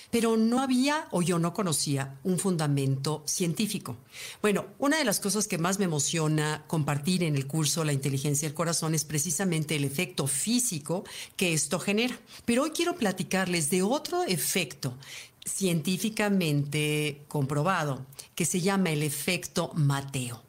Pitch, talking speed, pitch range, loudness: 170 Hz, 145 wpm, 150-195 Hz, -28 LUFS